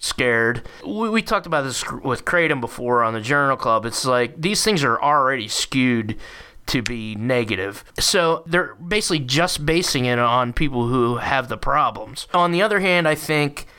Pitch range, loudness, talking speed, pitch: 120-170 Hz, -20 LUFS, 180 wpm, 140 Hz